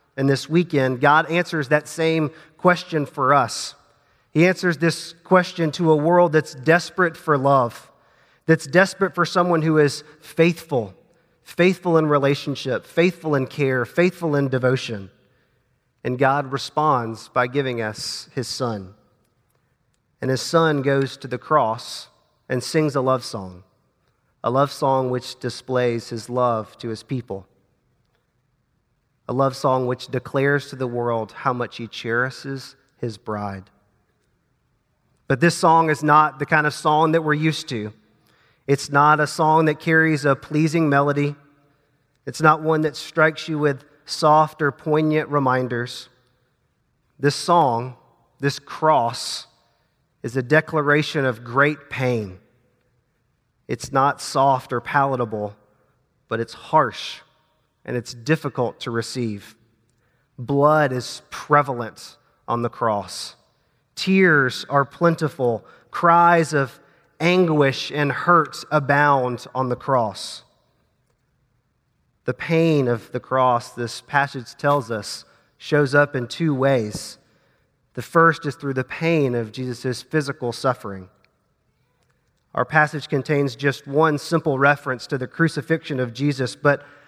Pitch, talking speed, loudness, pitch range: 140 Hz, 130 wpm, -20 LUFS, 125-155 Hz